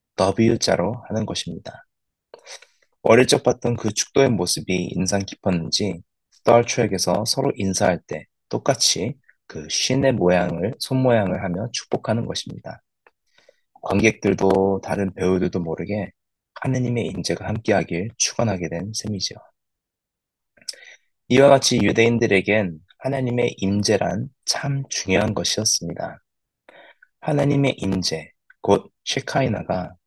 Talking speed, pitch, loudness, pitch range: 270 characters per minute, 105 Hz, -21 LUFS, 95-125 Hz